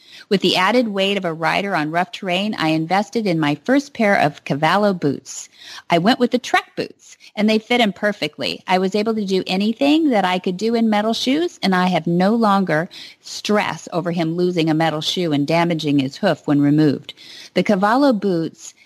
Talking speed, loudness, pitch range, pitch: 205 wpm, -18 LUFS, 165-220 Hz, 190 Hz